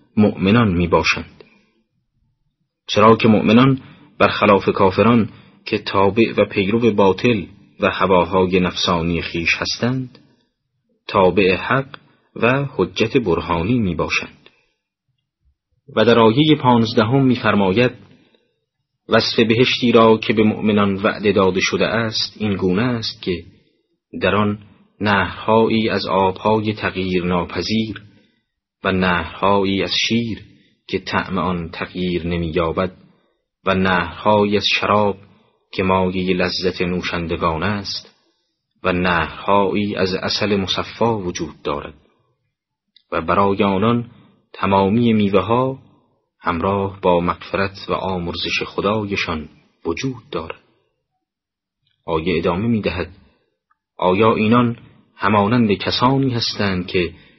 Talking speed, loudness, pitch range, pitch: 105 wpm, -18 LUFS, 95-115 Hz, 100 Hz